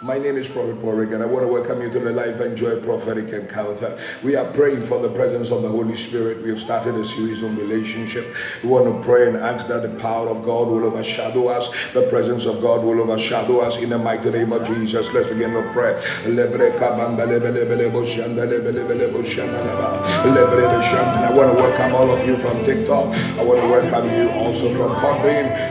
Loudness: -19 LUFS